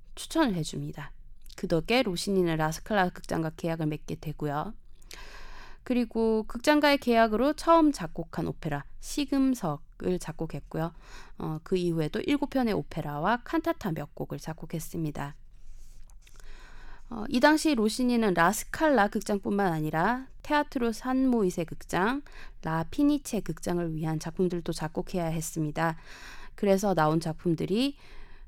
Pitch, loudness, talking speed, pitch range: 185 Hz, -28 LUFS, 300 characters per minute, 160-250 Hz